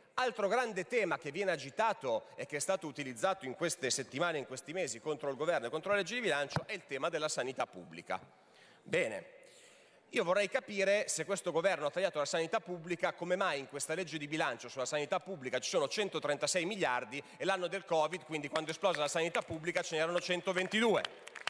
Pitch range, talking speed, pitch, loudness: 150-195 Hz, 200 wpm, 170 Hz, -35 LUFS